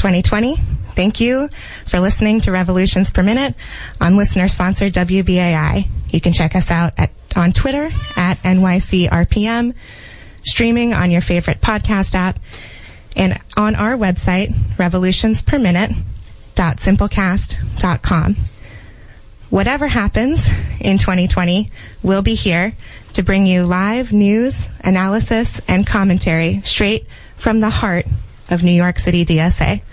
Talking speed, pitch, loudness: 115 wpm, 180 Hz, -15 LUFS